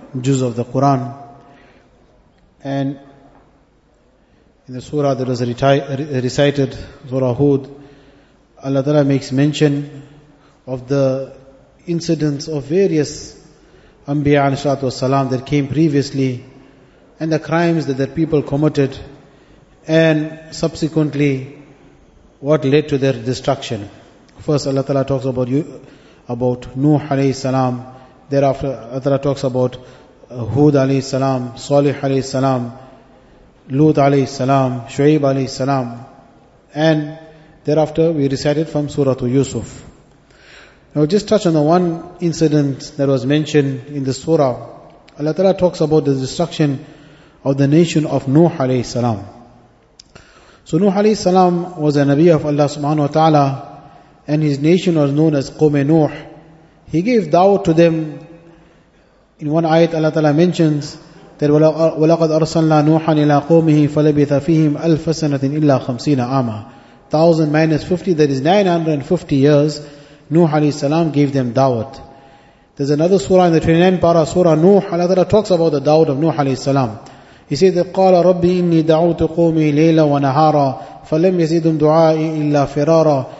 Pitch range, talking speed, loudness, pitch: 135-160 Hz, 135 wpm, -15 LUFS, 145 Hz